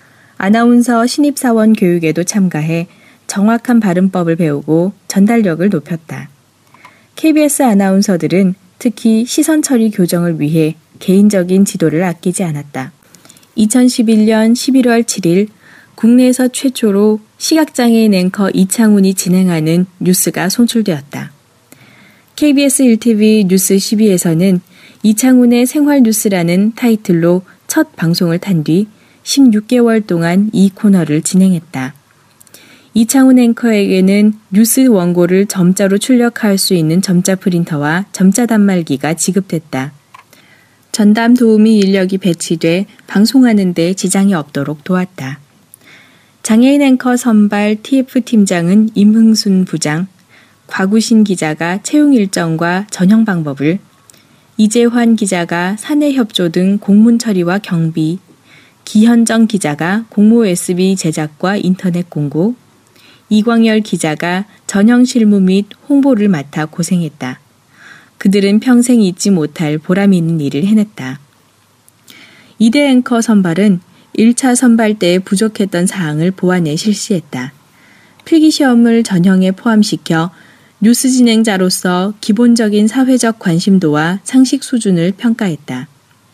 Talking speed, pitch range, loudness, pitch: 260 characters per minute, 175-225 Hz, -11 LUFS, 195 Hz